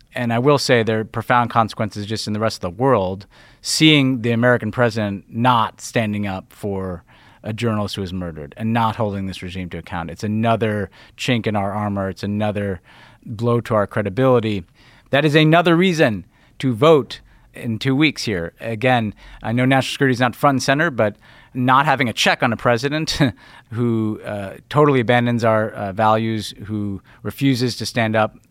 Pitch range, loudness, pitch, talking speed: 105-125 Hz, -19 LUFS, 115 Hz, 185 wpm